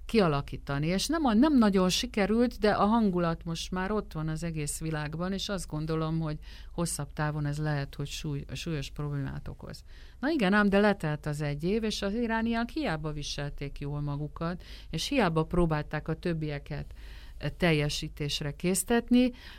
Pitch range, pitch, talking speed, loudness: 150-200 Hz, 160 Hz, 155 wpm, -30 LUFS